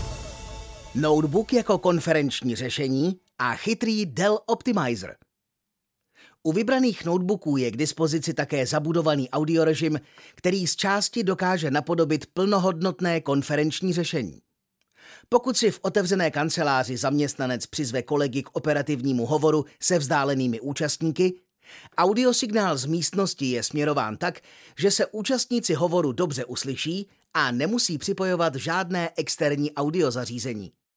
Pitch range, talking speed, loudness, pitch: 145-190 Hz, 110 wpm, -24 LUFS, 160 Hz